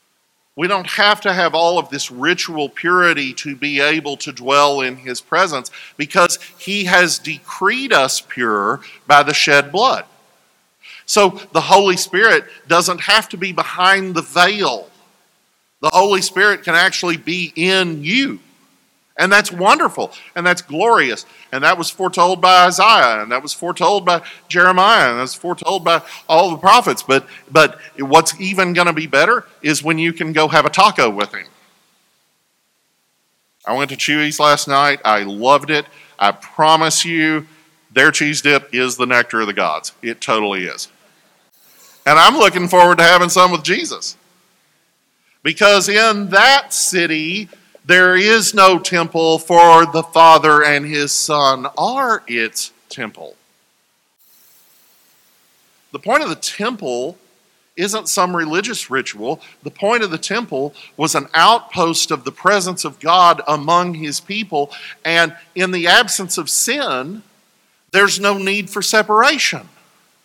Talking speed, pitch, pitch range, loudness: 150 wpm, 170 Hz, 150-190 Hz, -14 LUFS